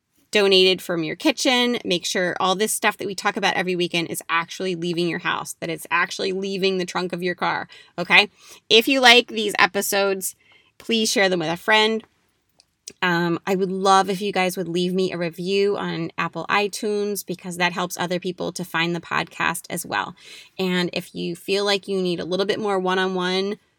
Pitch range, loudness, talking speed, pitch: 180-200 Hz, -21 LUFS, 205 wpm, 185 Hz